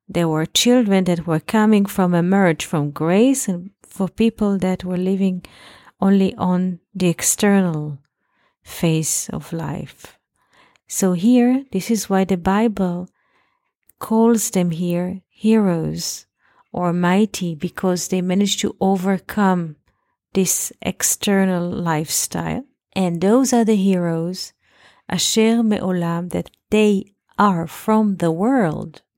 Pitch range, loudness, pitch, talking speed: 175-210 Hz, -19 LUFS, 190 Hz, 115 wpm